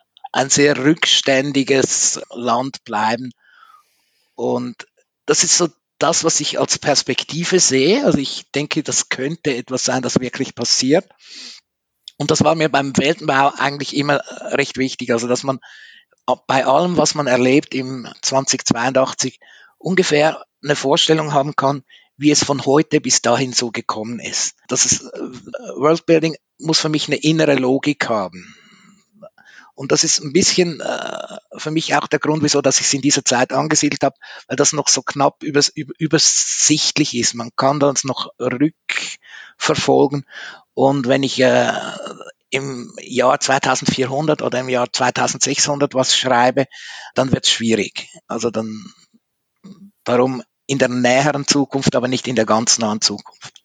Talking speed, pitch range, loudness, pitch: 150 wpm, 130-155 Hz, -17 LUFS, 140 Hz